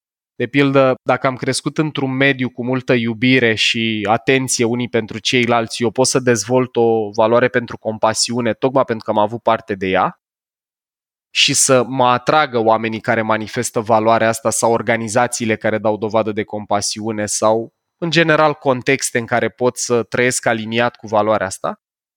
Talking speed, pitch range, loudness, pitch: 160 wpm, 110-130 Hz, -16 LUFS, 120 Hz